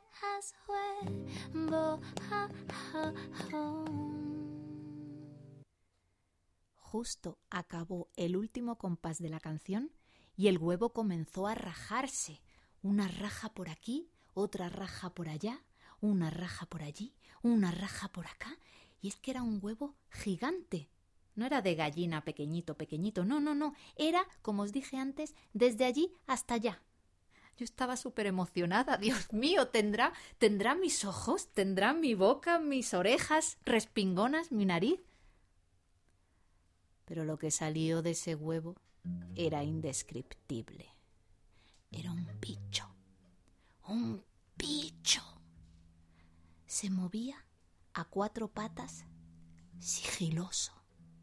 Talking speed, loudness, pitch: 110 wpm, -36 LUFS, 185 Hz